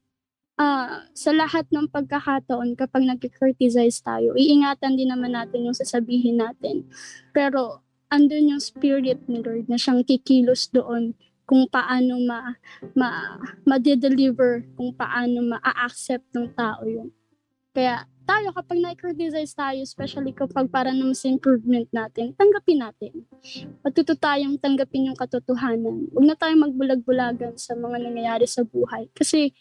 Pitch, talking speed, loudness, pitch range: 260 Hz, 130 wpm, -22 LUFS, 245-280 Hz